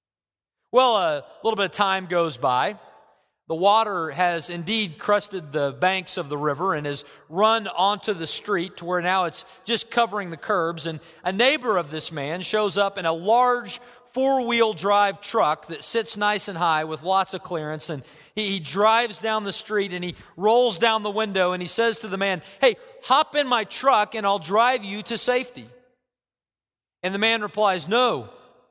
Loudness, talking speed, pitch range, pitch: -23 LUFS, 190 wpm, 175-230 Hz, 200 Hz